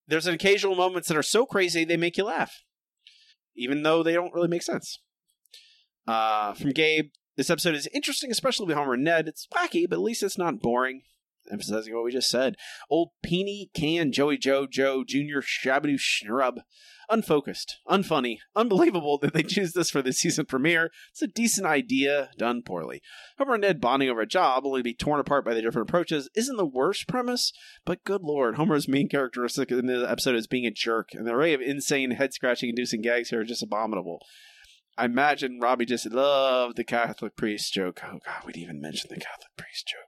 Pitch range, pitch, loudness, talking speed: 125-180 Hz, 145 Hz, -26 LUFS, 200 wpm